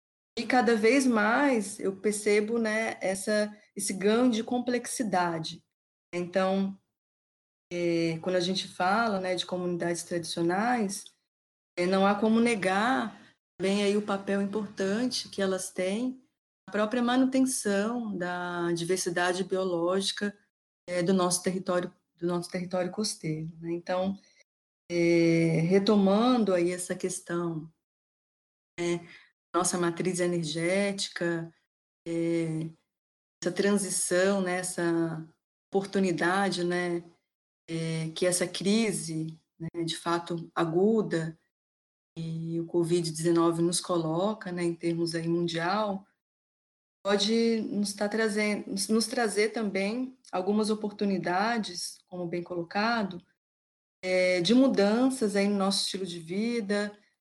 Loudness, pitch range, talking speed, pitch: -28 LUFS, 170-210 Hz, 110 wpm, 185 Hz